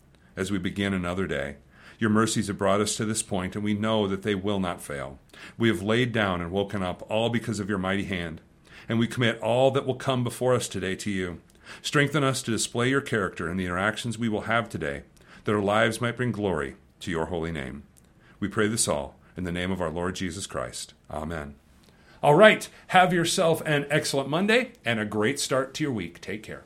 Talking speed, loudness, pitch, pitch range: 220 wpm, -26 LUFS, 105 Hz, 90-120 Hz